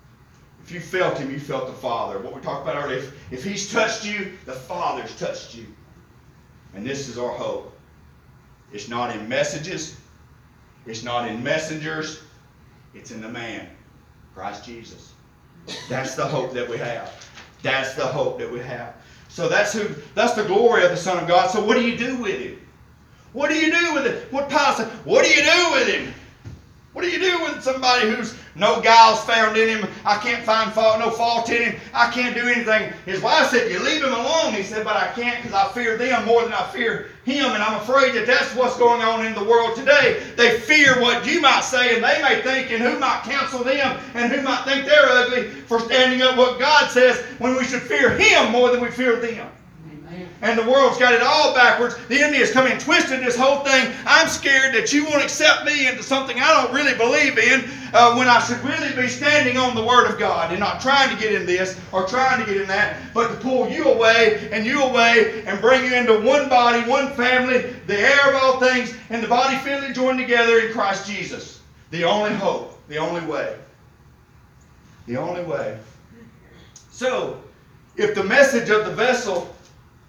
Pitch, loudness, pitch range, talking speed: 240 Hz, -18 LUFS, 210-265 Hz, 210 wpm